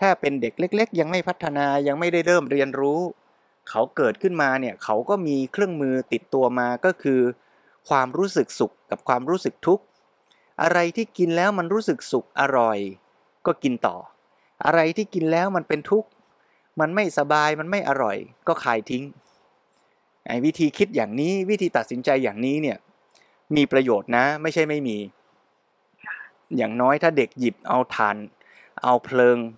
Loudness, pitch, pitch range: -23 LUFS, 150 Hz, 125-180 Hz